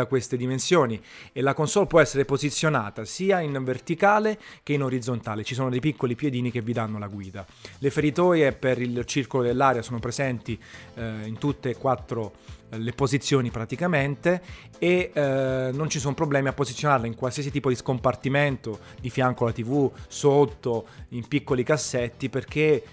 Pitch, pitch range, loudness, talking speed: 130 Hz, 120-145 Hz, -25 LUFS, 165 wpm